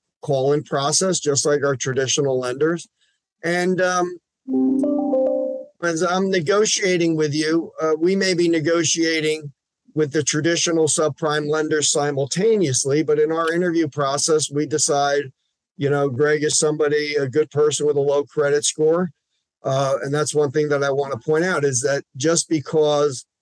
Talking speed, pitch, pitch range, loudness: 155 wpm, 155 Hz, 145-170 Hz, -20 LUFS